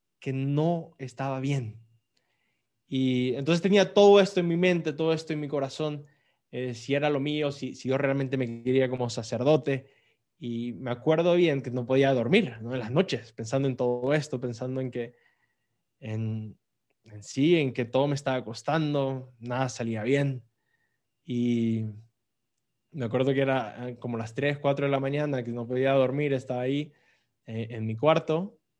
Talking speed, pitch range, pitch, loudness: 175 wpm, 120-145 Hz, 130 Hz, -27 LUFS